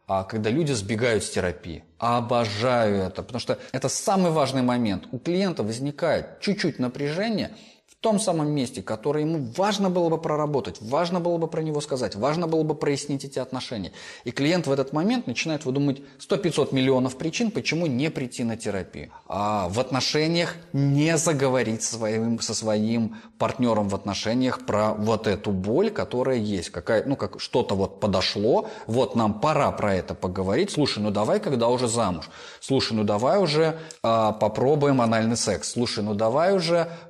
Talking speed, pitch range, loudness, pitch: 170 wpm, 110-155 Hz, -24 LUFS, 130 Hz